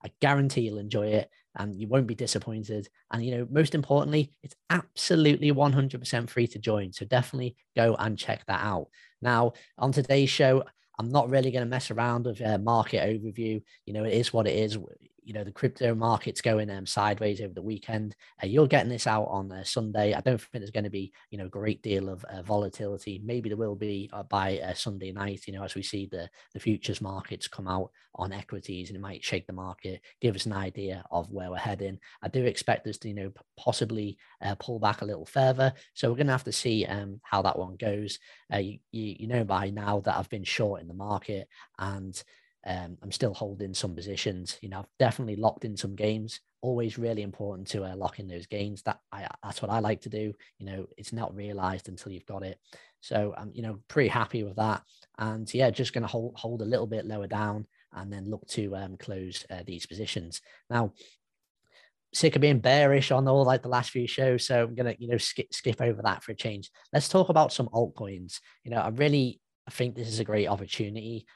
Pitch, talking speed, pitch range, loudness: 110 Hz, 225 wpm, 100-120 Hz, -29 LUFS